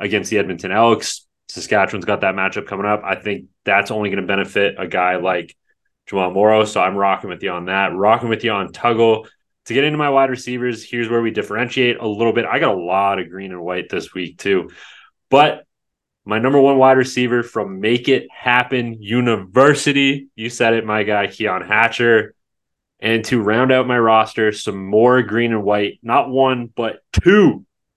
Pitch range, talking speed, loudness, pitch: 100-125 Hz, 195 wpm, -17 LUFS, 110 Hz